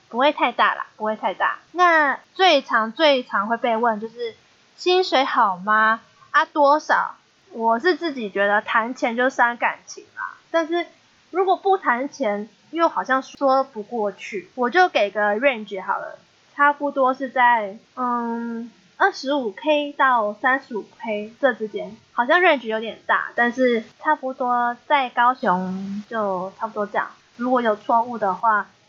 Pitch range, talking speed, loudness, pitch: 220-295 Hz, 235 characters per minute, -21 LUFS, 245 Hz